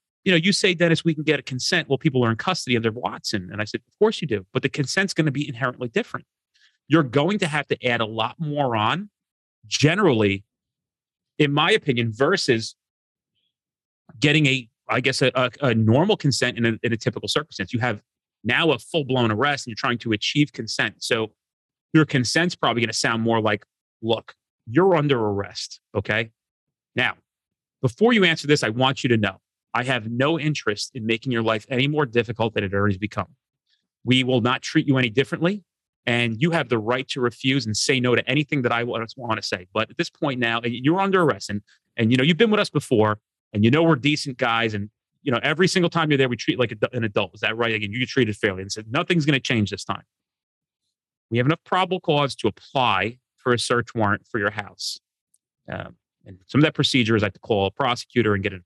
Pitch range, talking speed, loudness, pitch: 115-150 Hz, 225 wpm, -22 LUFS, 125 Hz